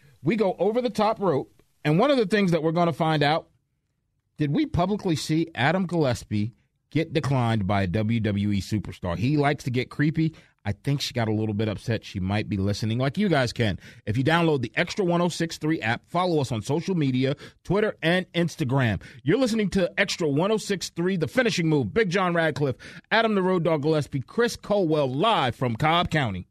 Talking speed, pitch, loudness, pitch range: 195 wpm, 150 Hz, -25 LUFS, 120-175 Hz